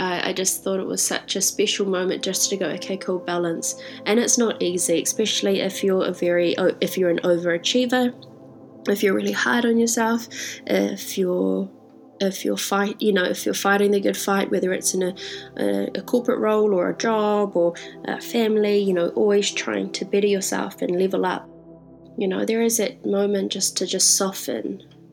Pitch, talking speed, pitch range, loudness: 195 Hz, 195 wpm, 180-210 Hz, -22 LUFS